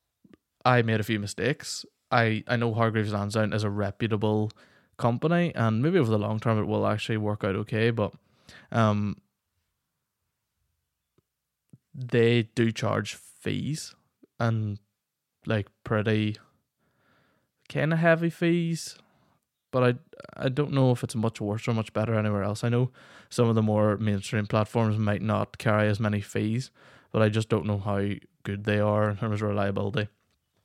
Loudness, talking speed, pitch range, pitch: -27 LUFS, 155 wpm, 105-120 Hz, 110 Hz